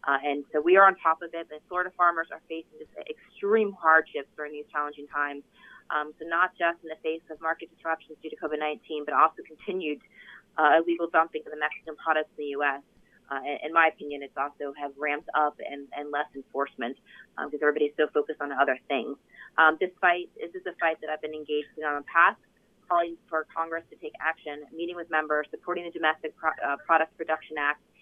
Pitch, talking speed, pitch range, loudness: 155 Hz, 215 wpm, 150-170 Hz, -27 LUFS